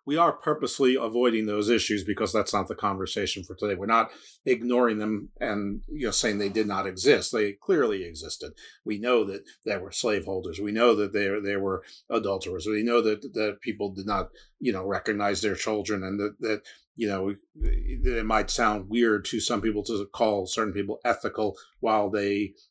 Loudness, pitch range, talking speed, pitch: -27 LUFS, 100-110 Hz, 190 wpm, 105 Hz